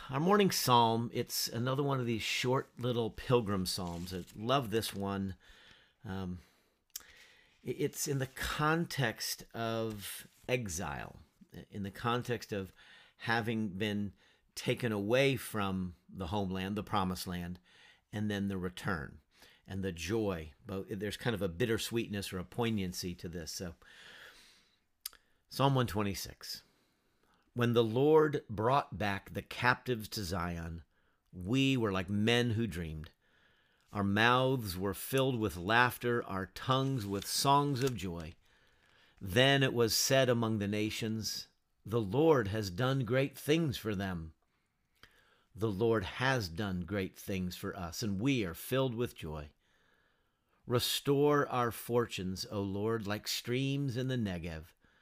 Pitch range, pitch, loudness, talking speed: 95-125 Hz, 110 Hz, -34 LUFS, 135 wpm